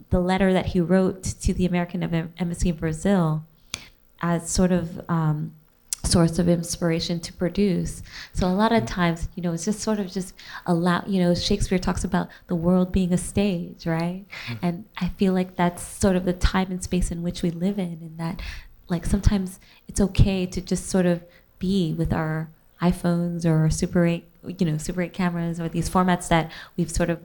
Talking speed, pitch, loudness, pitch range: 200 wpm, 175 Hz, -24 LUFS, 170-185 Hz